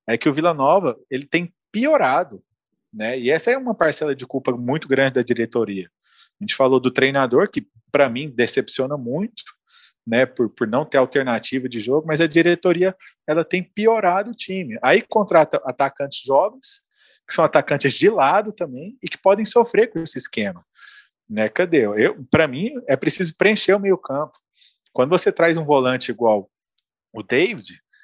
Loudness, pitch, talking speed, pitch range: -19 LUFS, 160 Hz, 175 wpm, 130-200 Hz